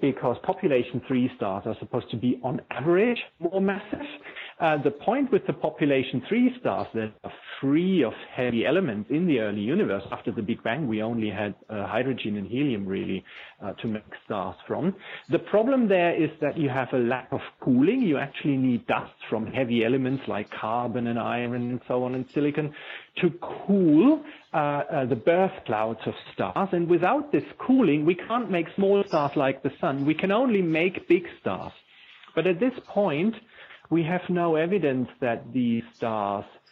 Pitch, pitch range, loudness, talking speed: 140 Hz, 120-185 Hz, -26 LUFS, 185 wpm